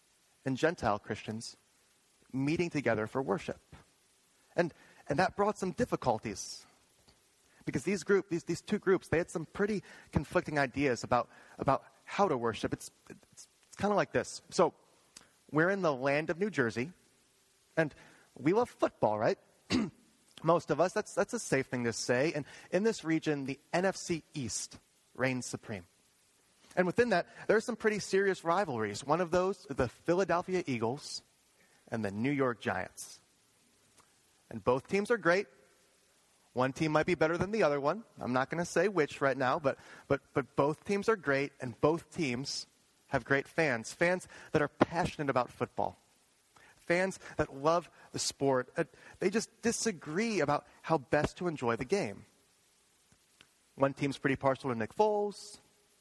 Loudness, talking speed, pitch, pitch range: -33 LUFS, 165 wpm, 150 Hz, 130-180 Hz